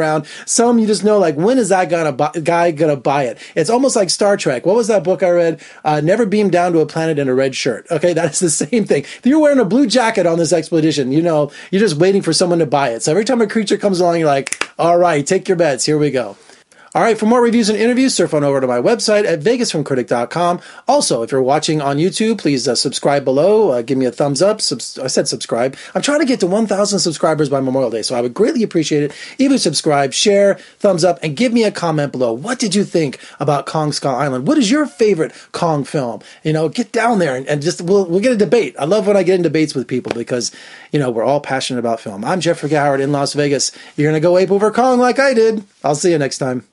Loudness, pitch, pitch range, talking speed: -15 LUFS, 170 Hz, 145-210 Hz, 260 wpm